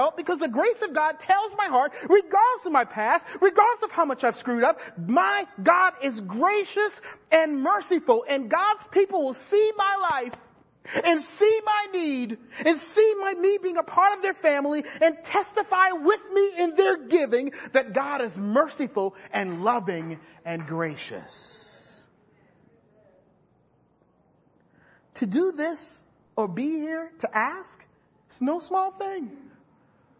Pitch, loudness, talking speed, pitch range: 330 Hz, -24 LUFS, 145 wpm, 265-395 Hz